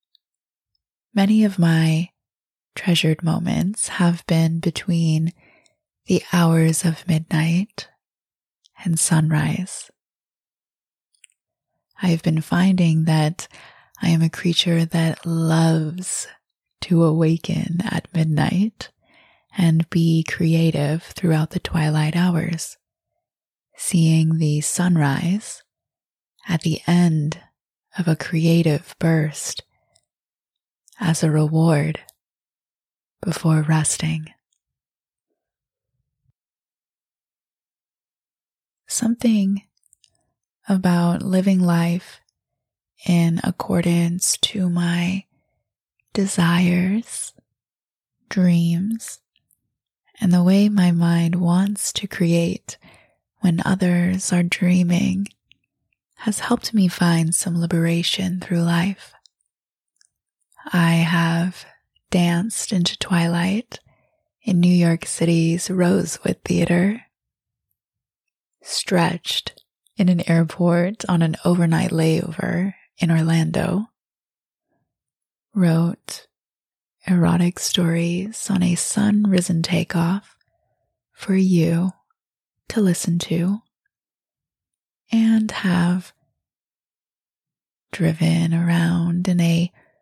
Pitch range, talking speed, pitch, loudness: 165-185 Hz, 80 wpm, 175 Hz, -20 LUFS